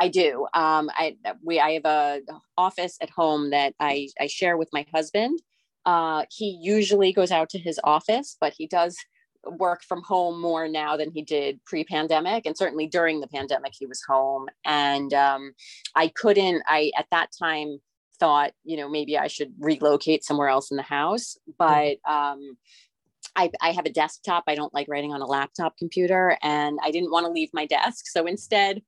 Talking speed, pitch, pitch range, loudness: 190 wpm, 155 Hz, 145-175 Hz, -24 LUFS